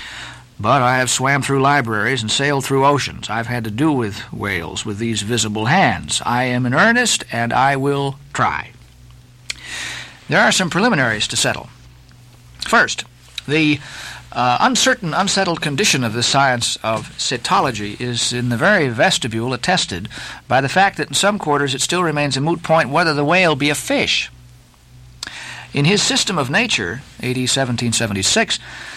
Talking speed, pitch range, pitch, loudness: 160 wpm, 115-150 Hz, 130 Hz, -17 LUFS